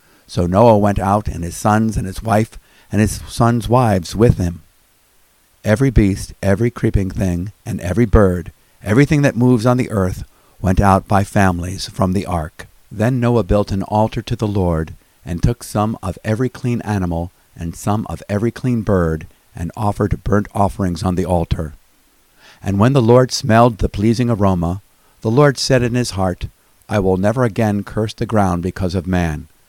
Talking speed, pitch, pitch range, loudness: 180 wpm, 100 Hz, 90-115 Hz, -17 LUFS